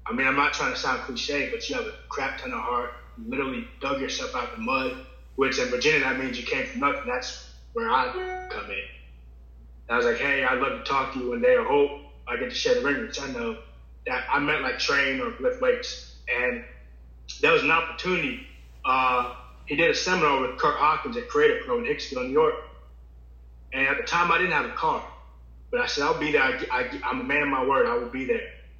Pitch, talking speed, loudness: 165 Hz, 245 wpm, -25 LUFS